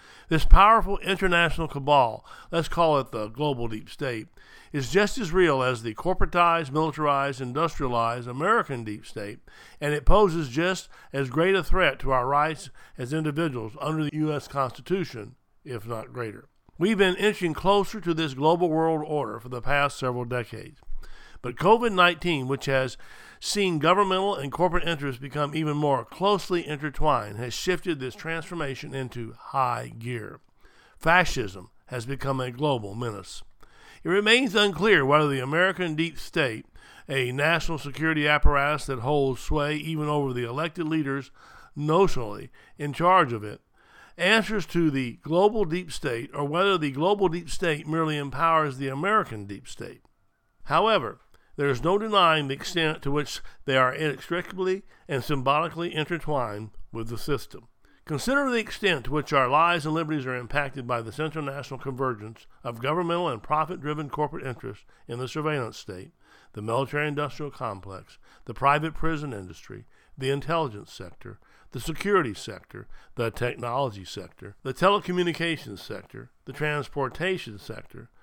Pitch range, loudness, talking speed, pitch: 130-170 Hz, -25 LUFS, 150 wpm, 150 Hz